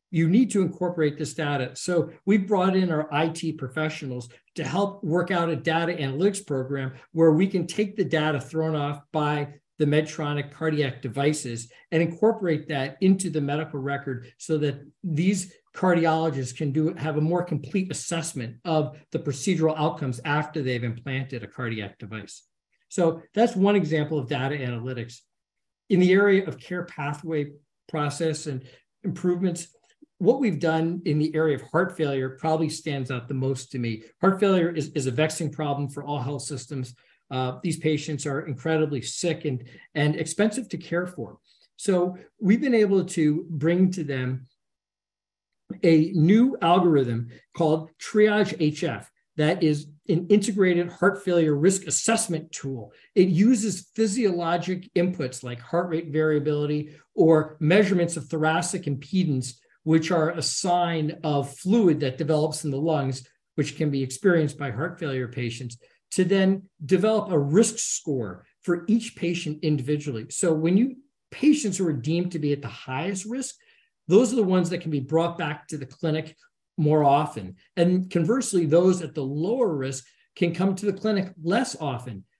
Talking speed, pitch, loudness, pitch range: 160 wpm, 160 Hz, -25 LUFS, 145-180 Hz